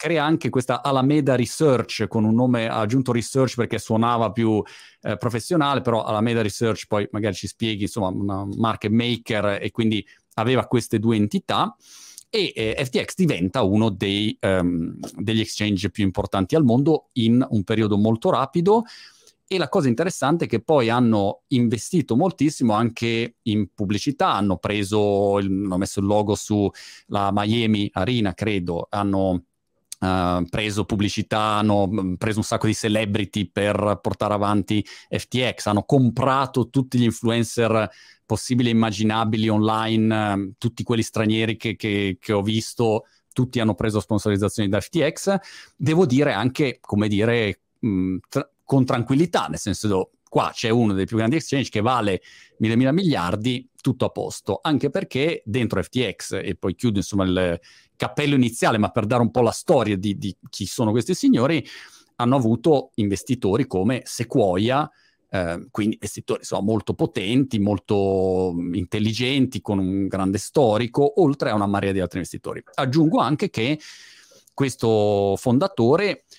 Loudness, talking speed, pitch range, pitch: -22 LUFS, 150 wpm, 100-125 Hz, 110 Hz